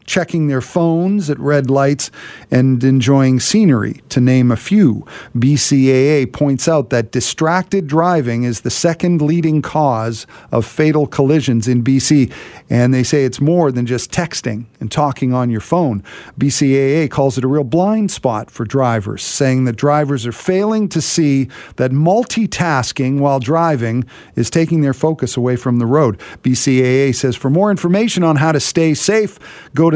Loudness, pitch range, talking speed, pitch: -15 LUFS, 125-160 Hz, 165 wpm, 140 Hz